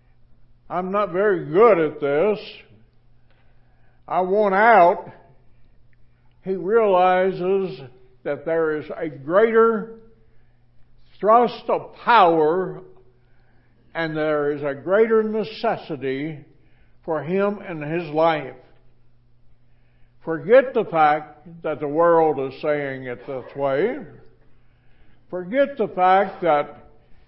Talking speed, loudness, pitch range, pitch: 100 wpm, -20 LUFS, 125-190 Hz, 155 Hz